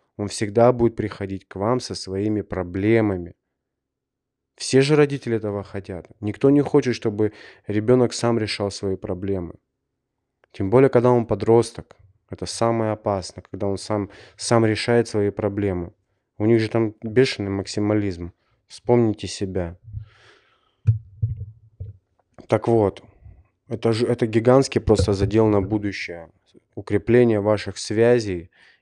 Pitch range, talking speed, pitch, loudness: 100-115 Hz, 125 wpm, 105 Hz, -21 LUFS